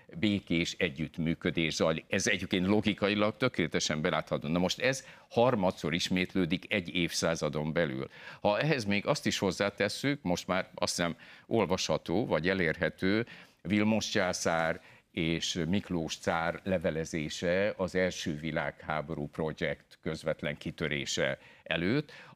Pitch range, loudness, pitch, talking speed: 80-100 Hz, -31 LUFS, 90 Hz, 115 wpm